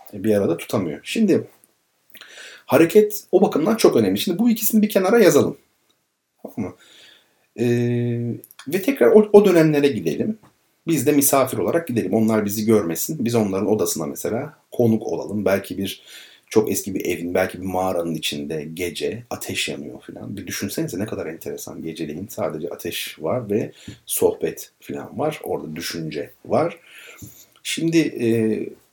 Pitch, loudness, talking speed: 115 Hz, -20 LUFS, 145 wpm